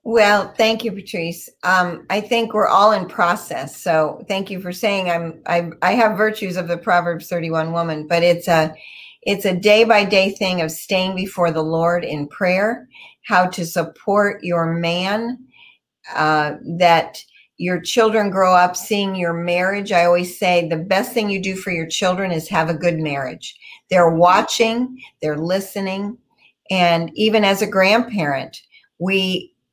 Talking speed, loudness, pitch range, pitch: 165 wpm, -18 LUFS, 170-205 Hz, 185 Hz